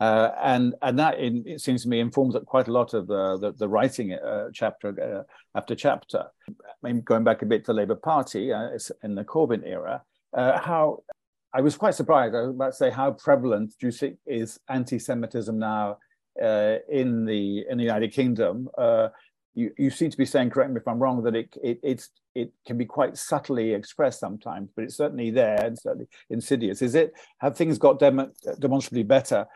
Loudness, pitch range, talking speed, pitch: -25 LUFS, 115-140 Hz, 205 wpm, 125 Hz